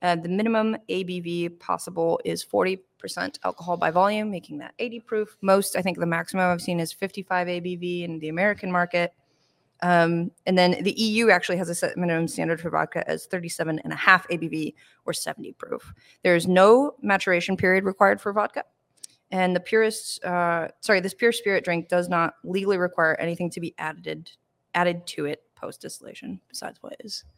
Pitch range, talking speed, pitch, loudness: 170-195 Hz, 175 wpm, 180 Hz, -24 LUFS